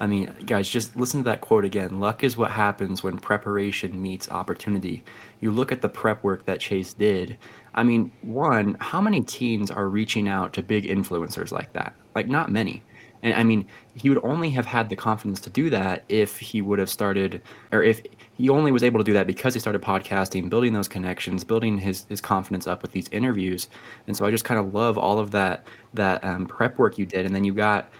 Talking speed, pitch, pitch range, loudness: 225 wpm, 105 Hz, 95-115 Hz, -24 LUFS